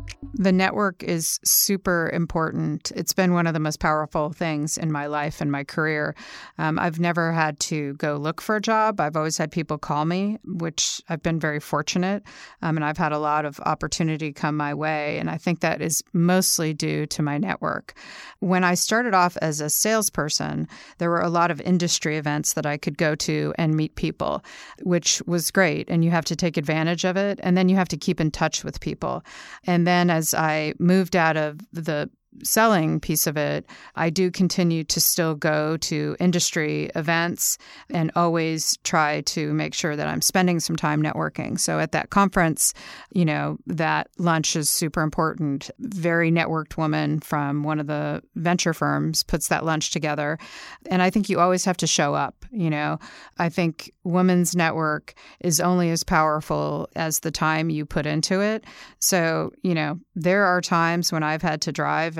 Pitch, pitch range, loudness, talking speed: 165 Hz, 155-180 Hz, -23 LUFS, 190 wpm